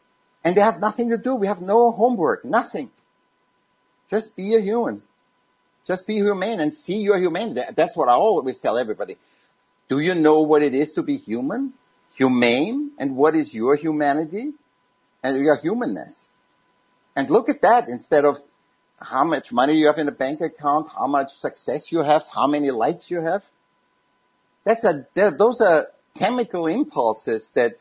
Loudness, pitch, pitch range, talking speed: -21 LUFS, 180 Hz, 150-230 Hz, 170 wpm